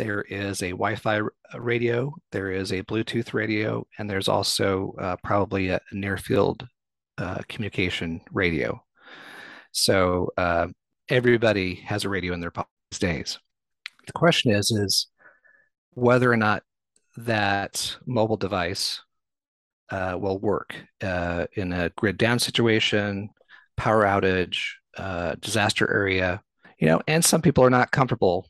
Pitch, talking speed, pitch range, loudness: 100 Hz, 130 wpm, 95-115 Hz, -24 LUFS